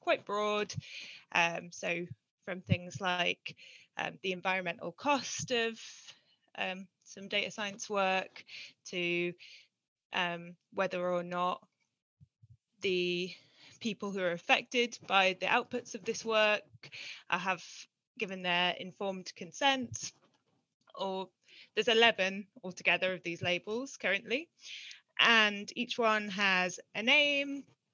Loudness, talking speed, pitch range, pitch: -32 LUFS, 115 wpm, 180-225 Hz, 190 Hz